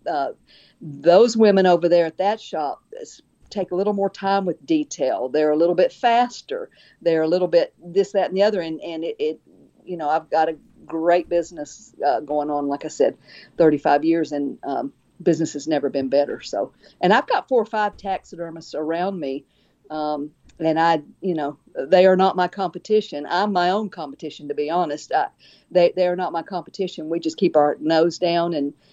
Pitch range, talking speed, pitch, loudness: 155-190 Hz, 200 wpm, 175 Hz, -21 LUFS